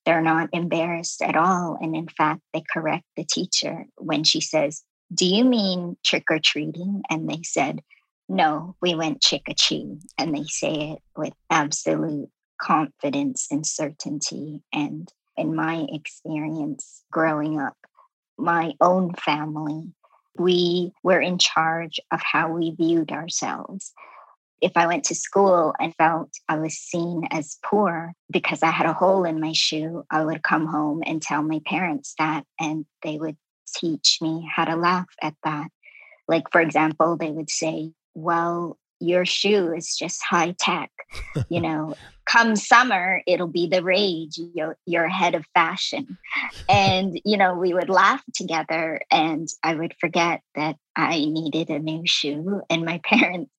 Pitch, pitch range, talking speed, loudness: 165 Hz, 155-180 Hz, 160 wpm, -22 LUFS